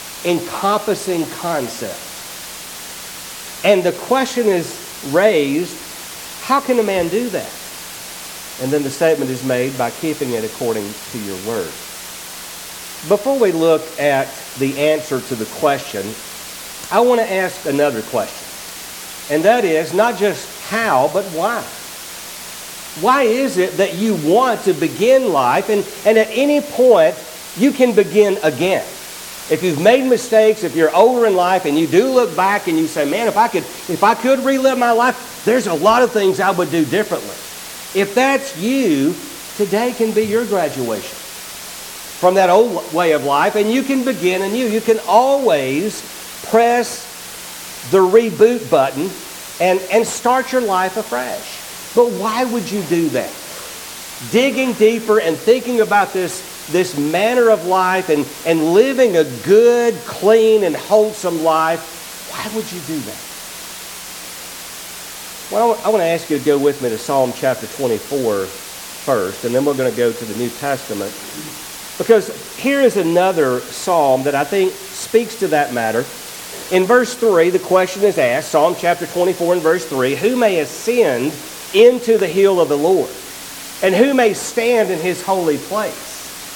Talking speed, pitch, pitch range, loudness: 160 wpm, 190 Hz, 155-225 Hz, -16 LUFS